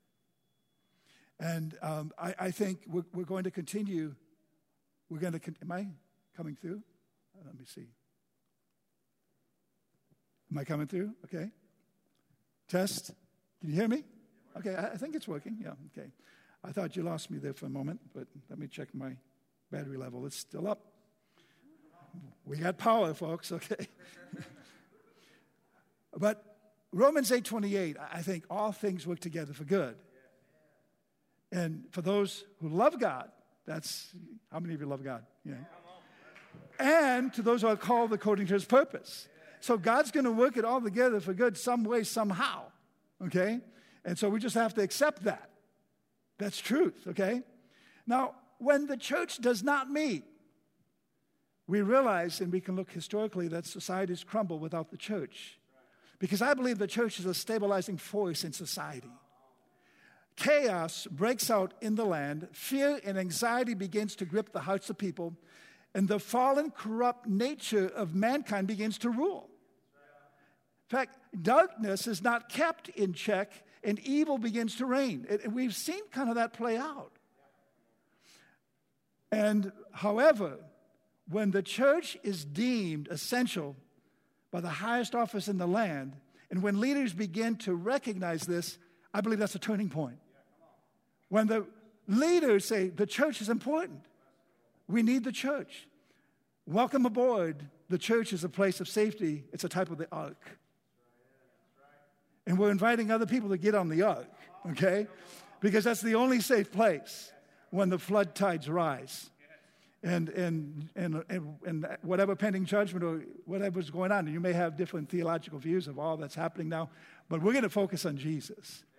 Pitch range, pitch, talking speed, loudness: 170-230 Hz, 195 Hz, 155 wpm, -32 LUFS